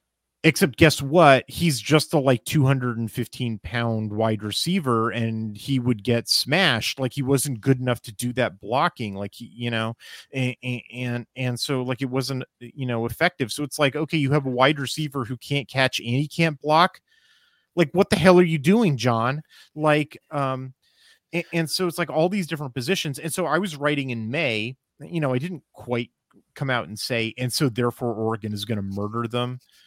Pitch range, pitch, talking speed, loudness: 120-155 Hz, 130 Hz, 195 wpm, -23 LUFS